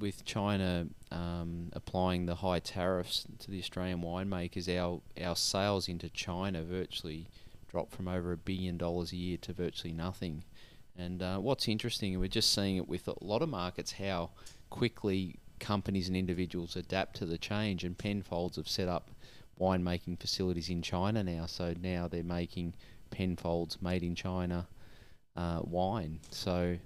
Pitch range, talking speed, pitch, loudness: 85-95 Hz, 160 wpm, 90 Hz, -36 LUFS